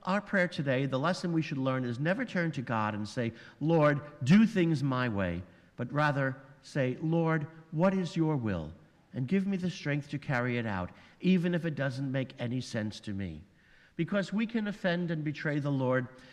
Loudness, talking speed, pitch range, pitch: -31 LUFS, 200 wpm, 125-170 Hz, 145 Hz